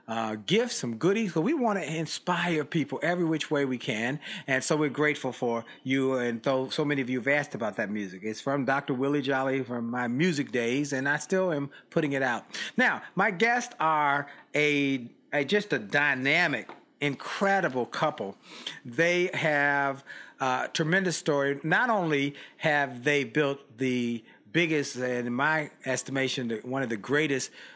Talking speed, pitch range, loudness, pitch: 175 wpm, 130-160 Hz, -28 LUFS, 140 Hz